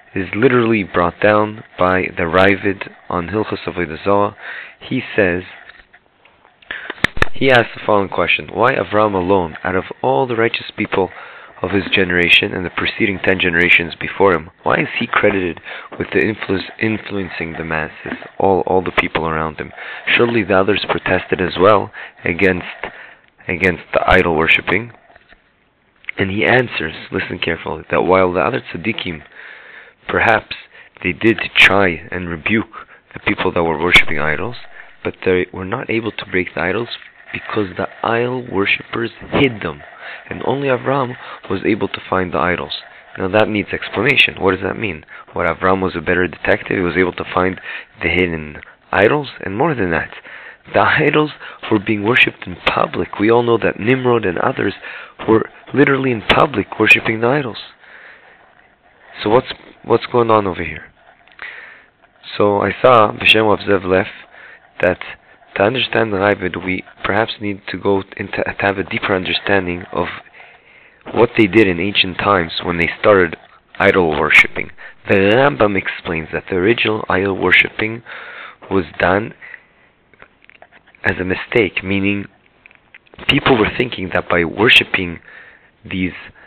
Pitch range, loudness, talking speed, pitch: 90-110 Hz, -16 LUFS, 155 wpm, 100 Hz